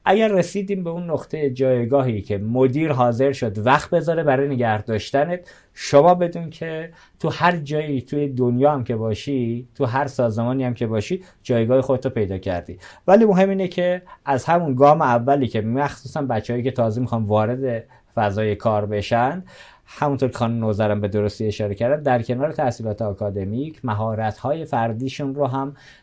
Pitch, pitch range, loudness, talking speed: 130 Hz, 115-150 Hz, -21 LUFS, 165 wpm